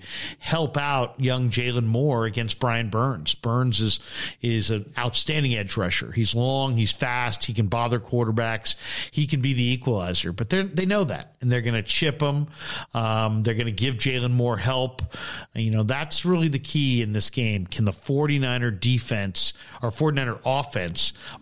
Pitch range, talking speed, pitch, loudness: 115-135 Hz, 190 wpm, 120 Hz, -24 LUFS